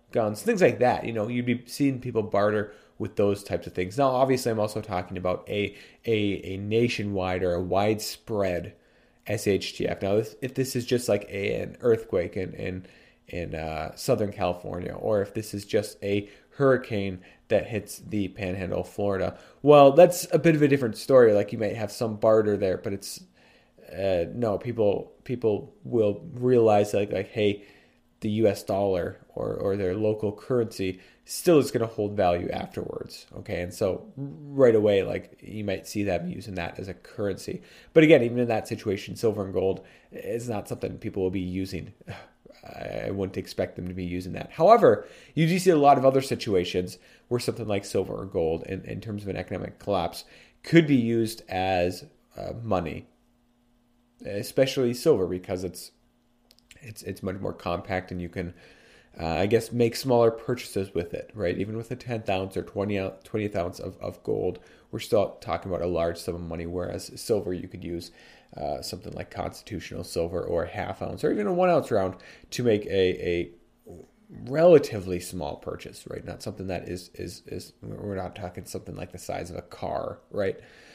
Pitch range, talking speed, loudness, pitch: 90-120 Hz, 190 wpm, -26 LUFS, 100 Hz